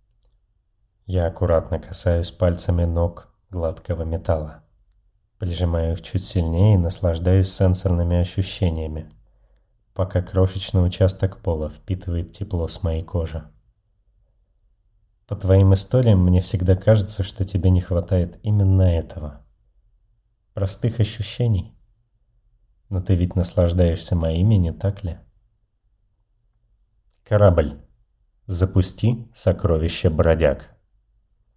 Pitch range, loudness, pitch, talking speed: 85-105 Hz, -21 LUFS, 95 Hz, 95 wpm